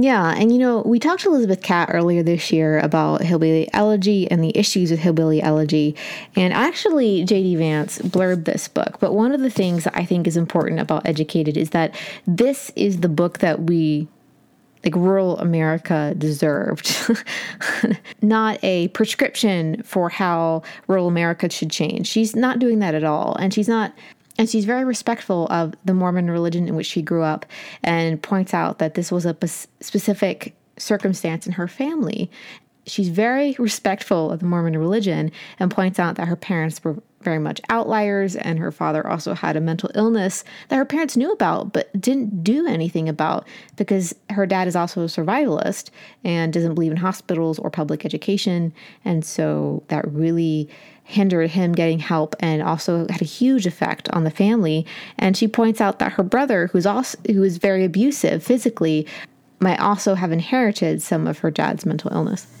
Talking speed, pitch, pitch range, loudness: 180 wpm, 185 Hz, 165-215 Hz, -20 LUFS